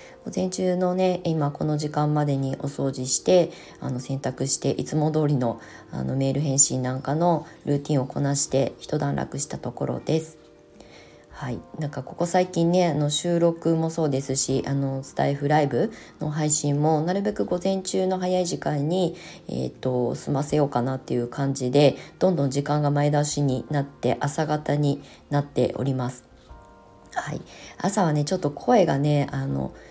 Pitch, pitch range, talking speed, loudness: 145 Hz, 135-165 Hz, 325 characters per minute, -24 LUFS